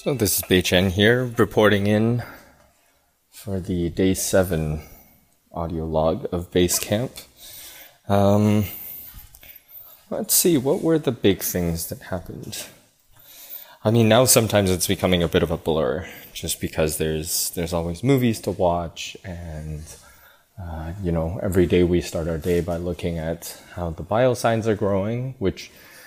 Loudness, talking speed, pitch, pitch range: -21 LUFS, 150 wpm, 90 Hz, 85-105 Hz